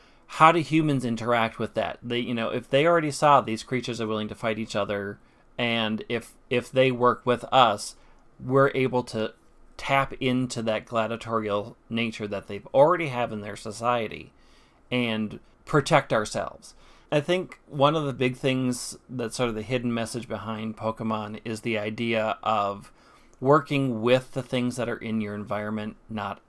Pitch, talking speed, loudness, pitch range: 115 Hz, 170 wpm, -26 LUFS, 110-130 Hz